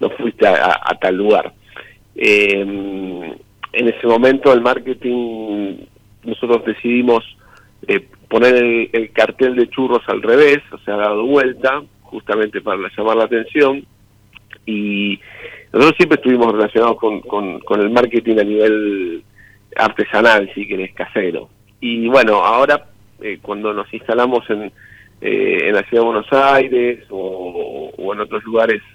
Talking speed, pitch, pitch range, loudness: 150 wpm, 115 Hz, 105-125 Hz, -15 LUFS